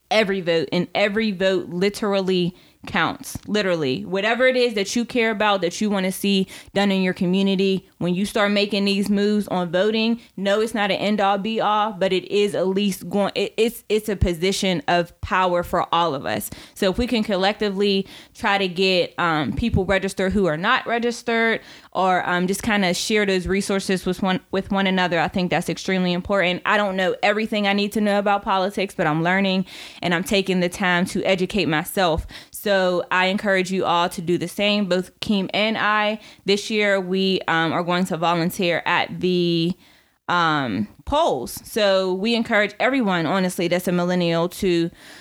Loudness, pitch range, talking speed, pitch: -21 LUFS, 180-205 Hz, 190 wpm, 195 Hz